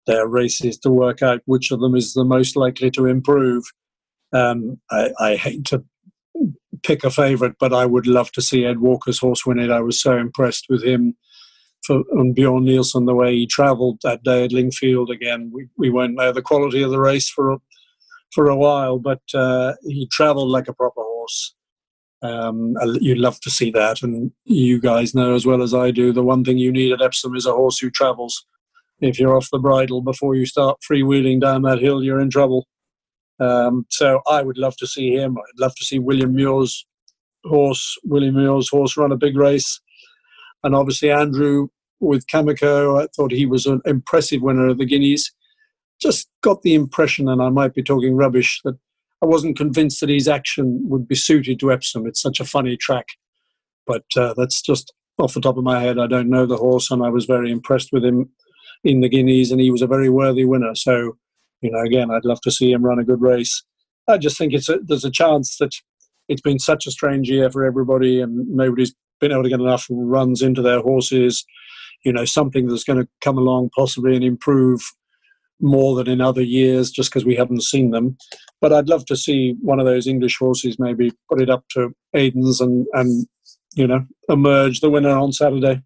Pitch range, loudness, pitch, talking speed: 125-140 Hz, -17 LUFS, 130 Hz, 210 wpm